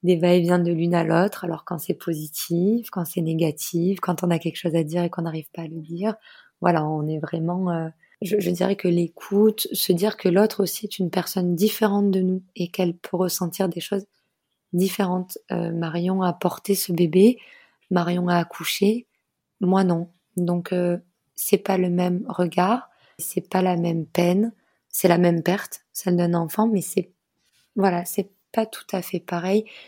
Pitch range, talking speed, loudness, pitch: 170-195 Hz, 190 wpm, -23 LUFS, 180 Hz